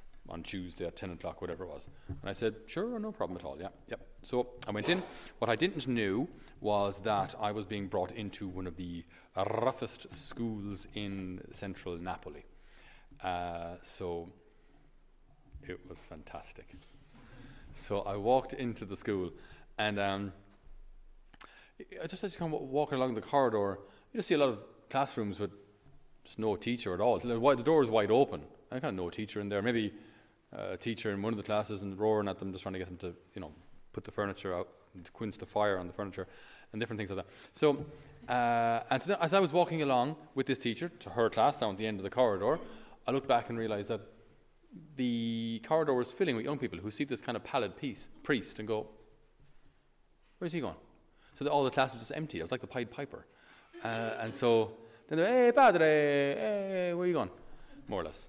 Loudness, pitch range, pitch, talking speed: -34 LUFS, 100-135 Hz, 110 Hz, 210 wpm